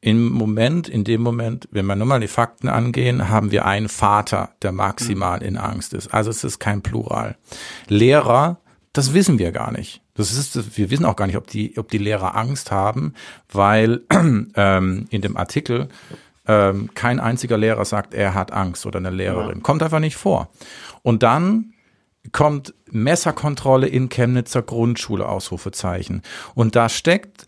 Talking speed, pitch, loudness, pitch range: 170 wpm, 110 Hz, -19 LUFS, 100-125 Hz